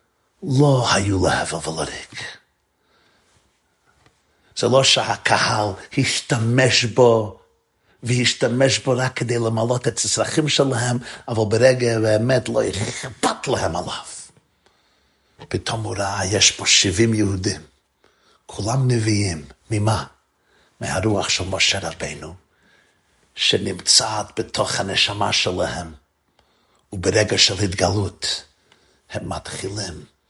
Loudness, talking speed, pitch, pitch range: -19 LUFS, 95 wpm, 110 Hz, 95-125 Hz